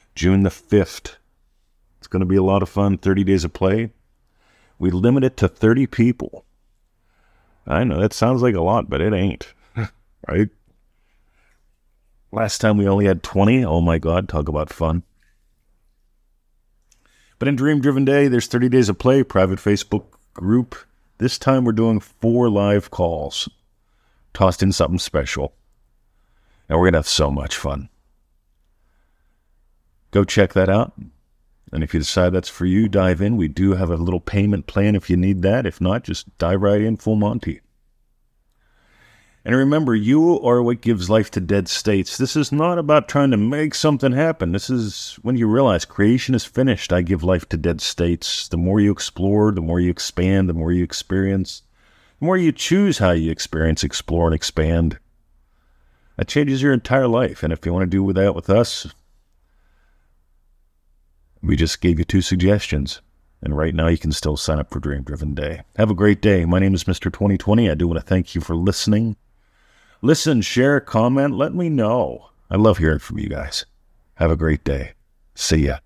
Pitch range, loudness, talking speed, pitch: 80-110 Hz, -19 LUFS, 180 wpm, 95 Hz